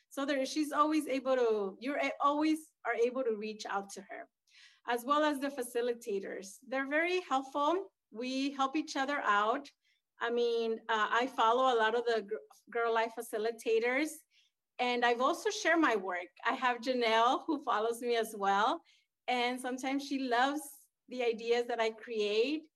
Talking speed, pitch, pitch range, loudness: 170 wpm, 245 Hz, 230-290 Hz, -33 LUFS